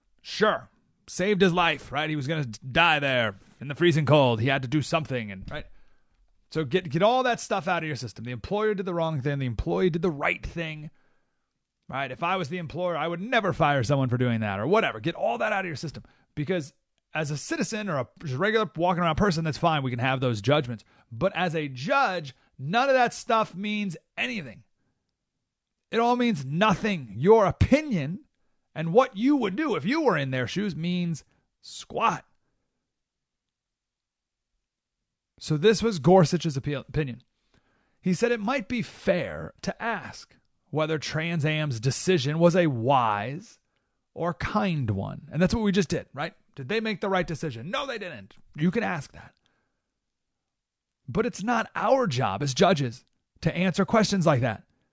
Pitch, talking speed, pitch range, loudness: 165 Hz, 185 wpm, 135-195 Hz, -26 LUFS